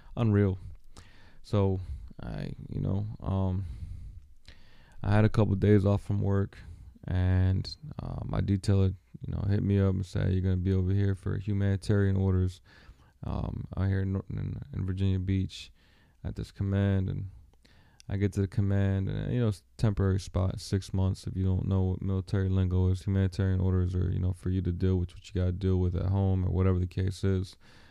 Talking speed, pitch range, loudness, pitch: 195 wpm, 95-100 Hz, -30 LUFS, 95 Hz